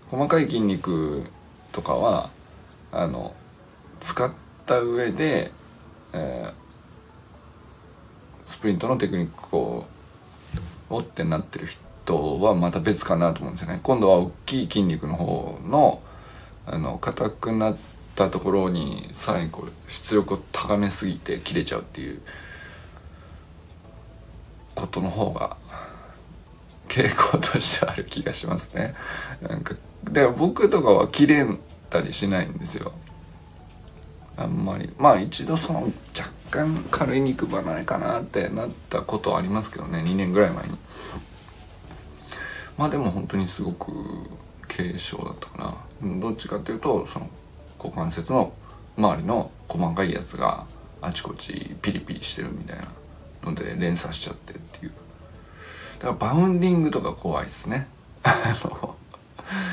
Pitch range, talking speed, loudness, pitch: 85-110 Hz, 260 characters per minute, -25 LUFS, 95 Hz